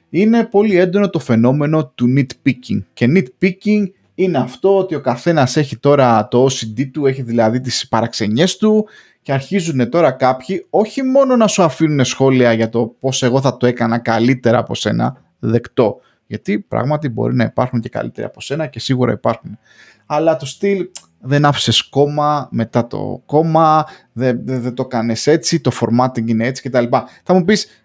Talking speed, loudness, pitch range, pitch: 170 wpm, -15 LUFS, 120-165 Hz, 130 Hz